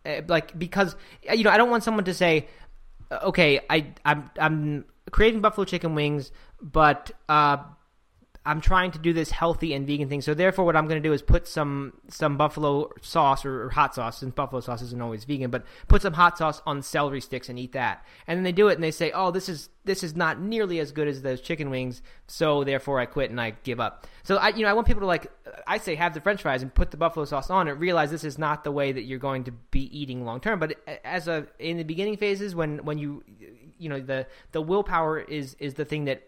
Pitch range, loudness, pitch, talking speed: 140-175 Hz, -25 LUFS, 150 Hz, 245 wpm